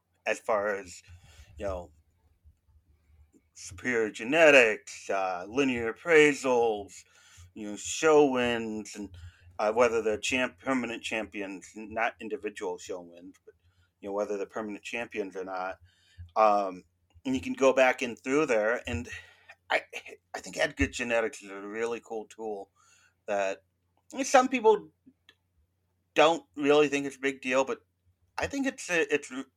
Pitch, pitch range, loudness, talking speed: 105 Hz, 90-130 Hz, -28 LUFS, 150 wpm